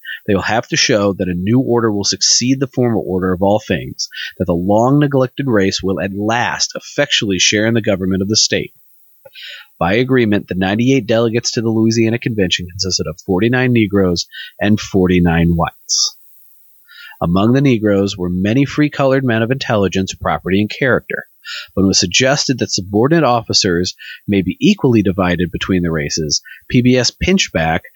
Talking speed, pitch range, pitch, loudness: 175 wpm, 95-125 Hz, 105 Hz, -15 LUFS